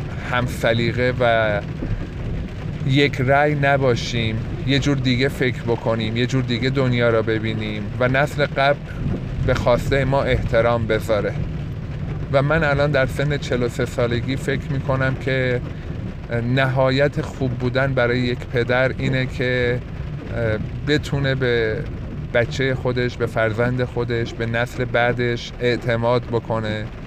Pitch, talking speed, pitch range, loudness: 125 Hz, 120 wpm, 120-135 Hz, -21 LUFS